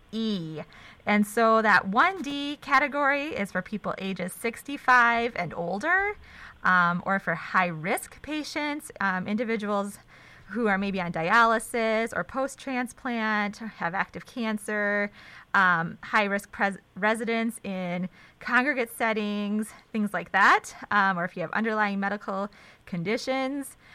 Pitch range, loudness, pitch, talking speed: 190-245 Hz, -26 LUFS, 215 Hz, 125 wpm